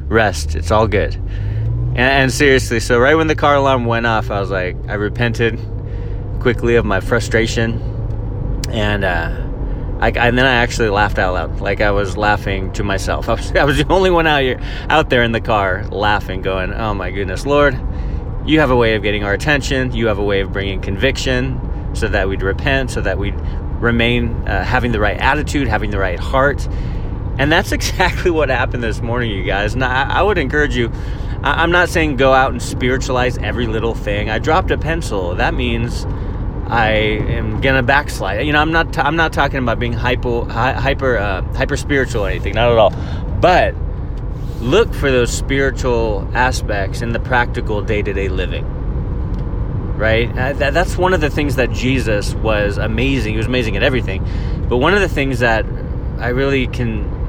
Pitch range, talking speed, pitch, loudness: 100-125 Hz, 190 wpm, 115 Hz, -16 LUFS